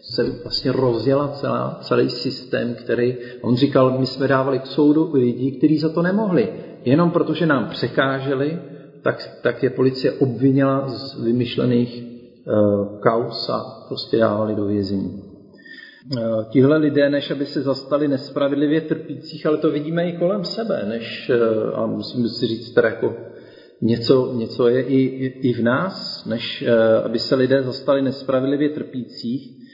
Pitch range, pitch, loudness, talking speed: 120-150 Hz, 135 Hz, -20 LUFS, 155 wpm